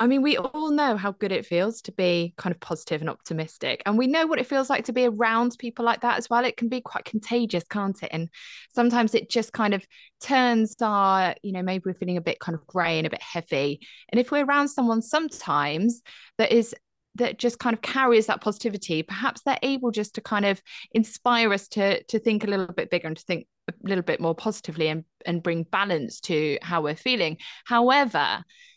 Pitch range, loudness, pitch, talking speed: 175-240 Hz, -25 LUFS, 215 Hz, 225 wpm